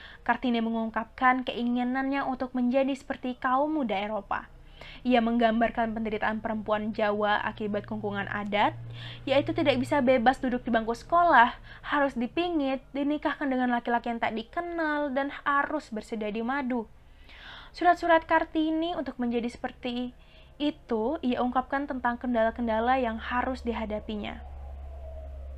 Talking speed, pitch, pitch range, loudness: 120 wpm, 245 Hz, 220-275 Hz, -28 LUFS